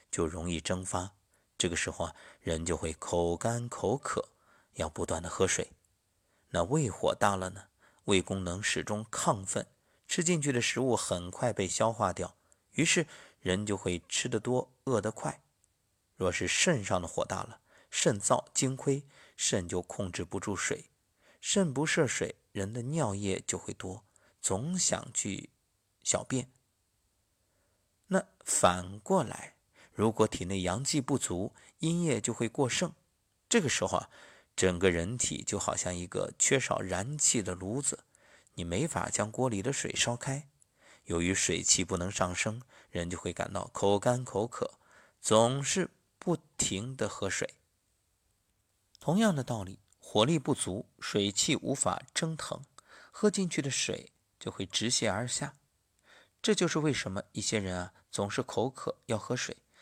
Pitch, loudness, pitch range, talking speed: 105 Hz, -32 LUFS, 95-130 Hz, 210 characters per minute